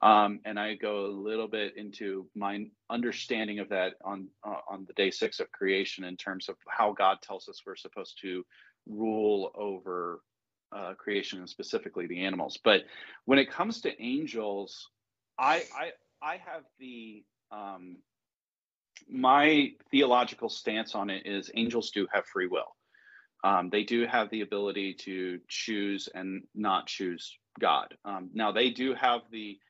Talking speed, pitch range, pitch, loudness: 160 wpm, 100-120 Hz, 105 Hz, -31 LUFS